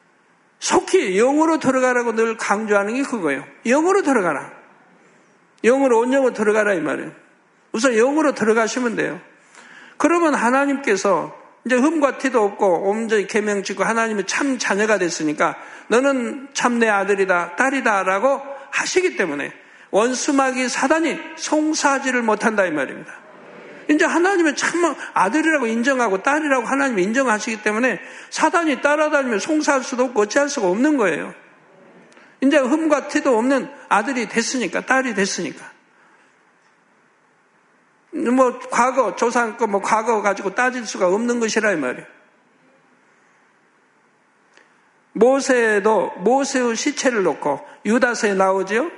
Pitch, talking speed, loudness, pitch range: 255 Hz, 310 characters per minute, -19 LUFS, 220-285 Hz